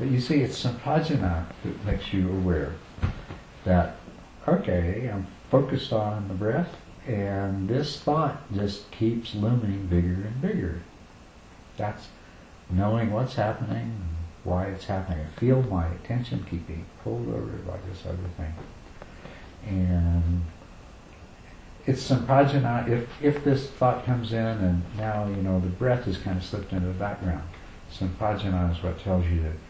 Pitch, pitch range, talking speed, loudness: 100 Hz, 90-120 Hz, 150 wpm, -27 LUFS